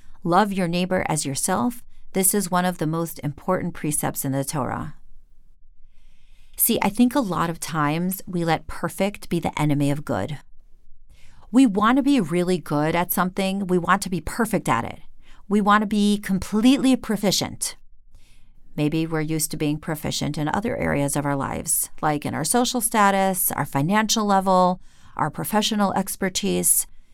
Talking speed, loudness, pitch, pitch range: 165 wpm, -22 LUFS, 180 Hz, 145-200 Hz